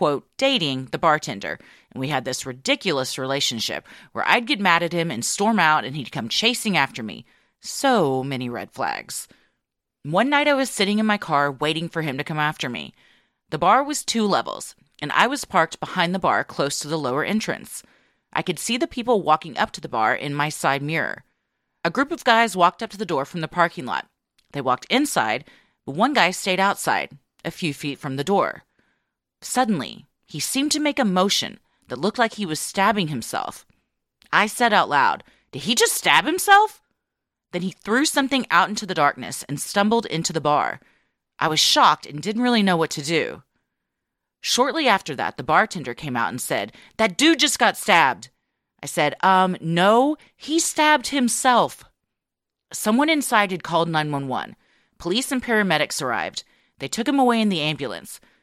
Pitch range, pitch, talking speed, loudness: 150-235 Hz, 185 Hz, 190 wpm, -21 LUFS